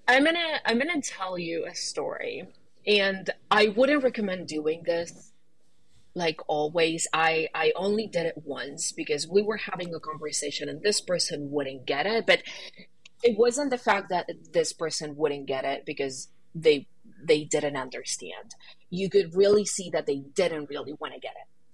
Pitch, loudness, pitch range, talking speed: 175 Hz, -27 LUFS, 155-210 Hz, 170 wpm